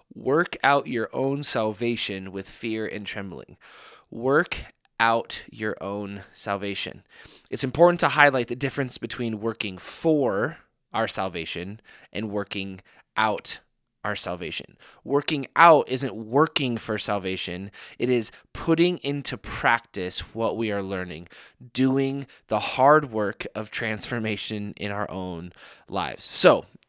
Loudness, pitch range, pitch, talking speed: -25 LUFS, 100-135 Hz, 110 Hz, 125 wpm